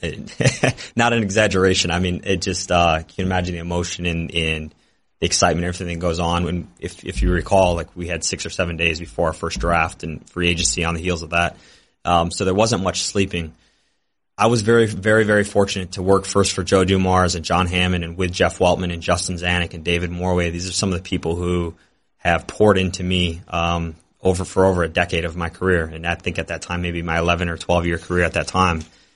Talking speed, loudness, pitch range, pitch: 230 wpm, -20 LUFS, 85-95 Hz, 90 Hz